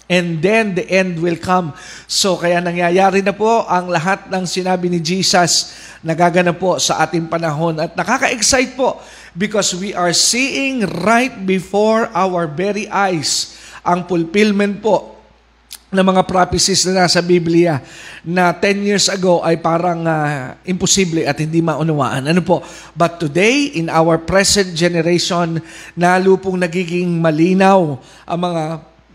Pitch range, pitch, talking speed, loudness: 170-195 Hz, 180 Hz, 140 wpm, -15 LUFS